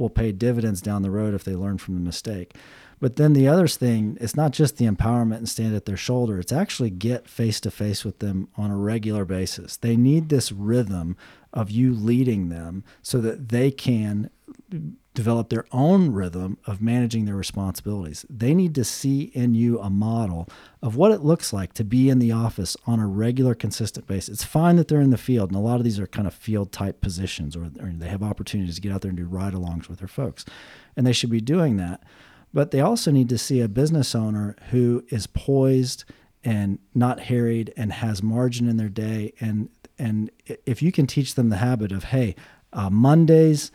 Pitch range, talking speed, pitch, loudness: 100-125 Hz, 215 wpm, 115 Hz, -23 LUFS